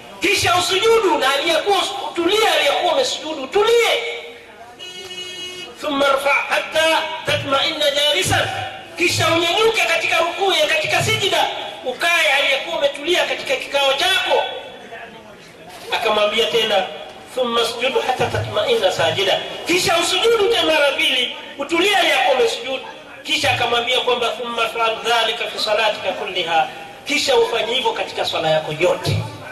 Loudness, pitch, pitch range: -17 LUFS, 290 Hz, 235-350 Hz